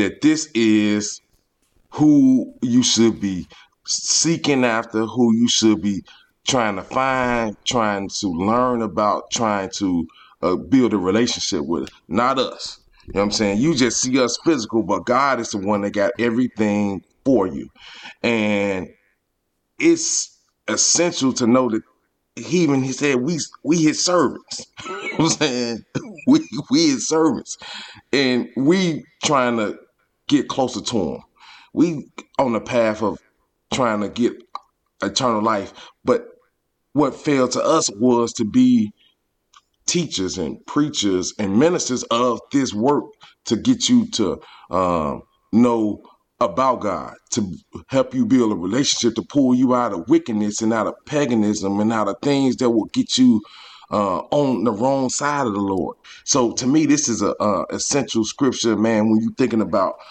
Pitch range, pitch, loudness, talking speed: 110-175 Hz, 125 Hz, -19 LUFS, 155 wpm